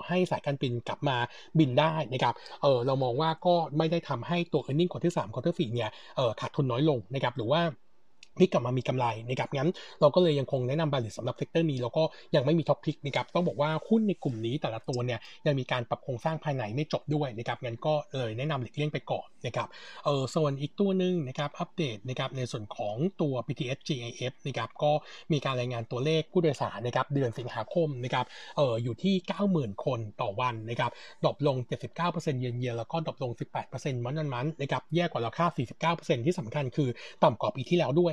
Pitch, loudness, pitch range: 145 Hz, -30 LUFS, 125-160 Hz